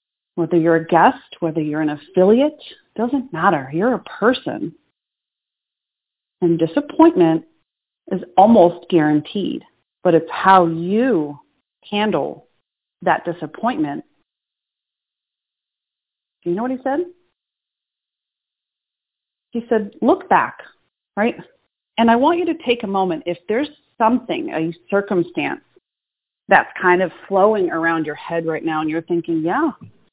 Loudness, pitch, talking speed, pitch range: -18 LUFS, 190 Hz, 125 wpm, 165-250 Hz